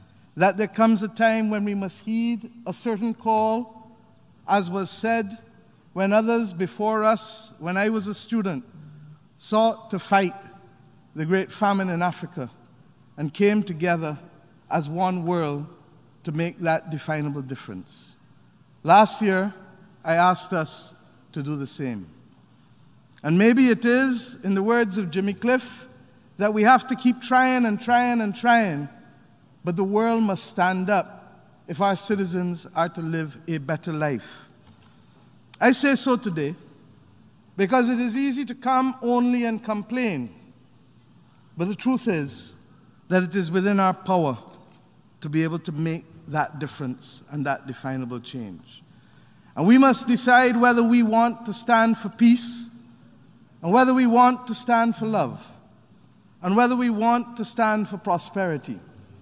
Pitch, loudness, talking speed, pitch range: 195 Hz, -22 LUFS, 150 wpm, 160-230 Hz